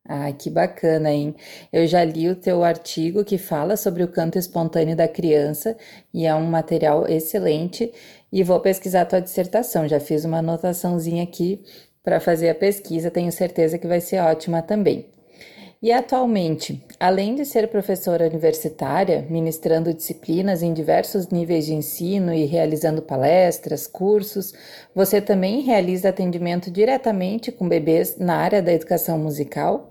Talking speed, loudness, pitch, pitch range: 150 wpm, -21 LUFS, 175 Hz, 160-195 Hz